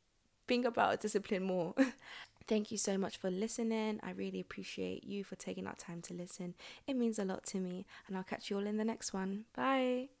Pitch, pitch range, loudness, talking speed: 200 Hz, 185-220 Hz, -38 LUFS, 205 wpm